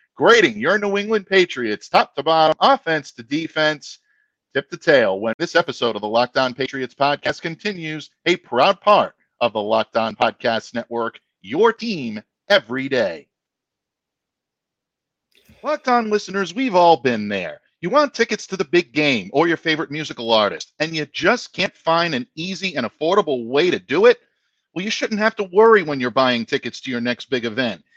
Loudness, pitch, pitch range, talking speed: -19 LUFS, 165 Hz, 130-210 Hz, 175 wpm